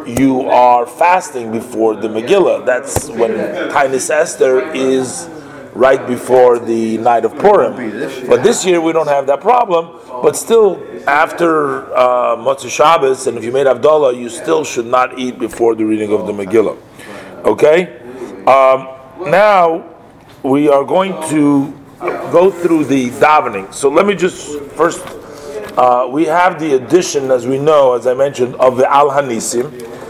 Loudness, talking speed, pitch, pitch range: -13 LUFS, 155 wpm, 135 Hz, 125-165 Hz